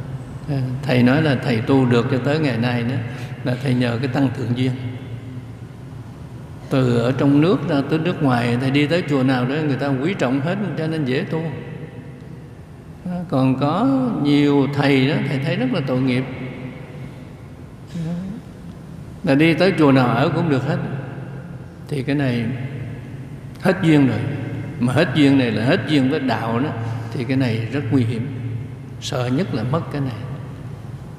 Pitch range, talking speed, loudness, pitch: 125-145 Hz, 170 wpm, -19 LUFS, 135 Hz